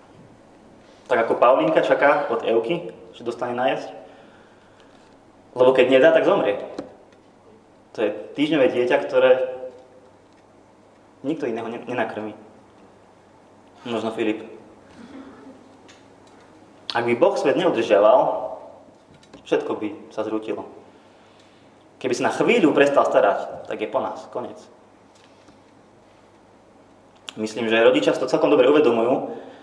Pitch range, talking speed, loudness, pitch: 110-135 Hz, 105 wpm, -20 LUFS, 115 Hz